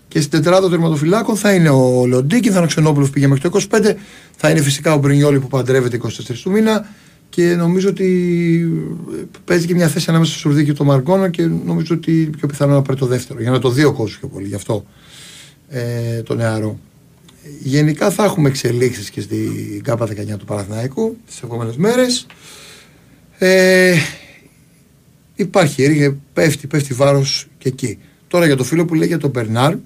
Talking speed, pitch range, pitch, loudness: 180 wpm, 130-175 Hz, 150 Hz, -15 LUFS